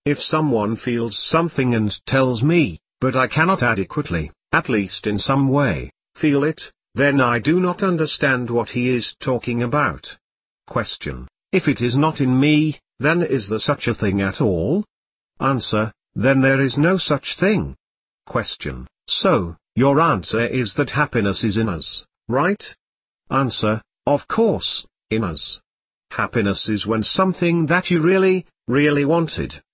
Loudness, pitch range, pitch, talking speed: -20 LUFS, 110-150 Hz, 130 Hz, 150 wpm